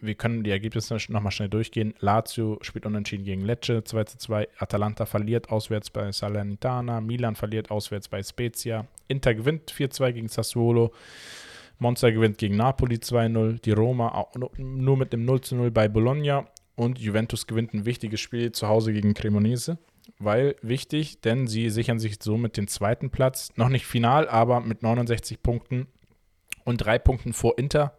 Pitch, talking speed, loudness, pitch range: 115 Hz, 170 wpm, -26 LUFS, 105-120 Hz